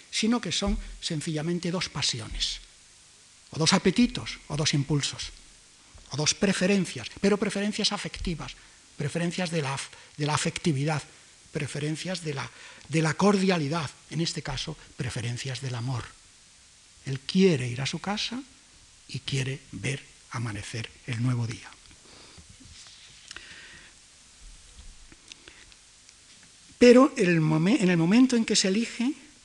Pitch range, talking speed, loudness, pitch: 130-190 Hz, 115 wpm, -27 LUFS, 155 Hz